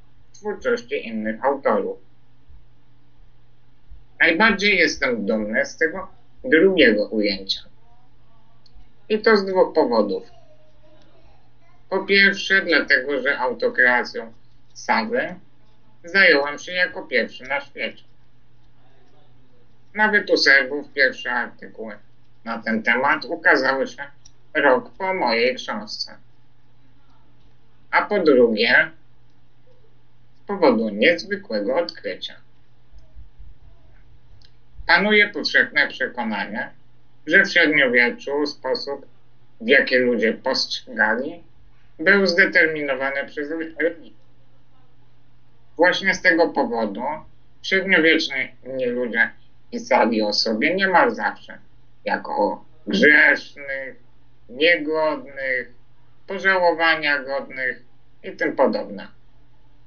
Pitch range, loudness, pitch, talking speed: 125-185 Hz, -19 LUFS, 140 Hz, 80 wpm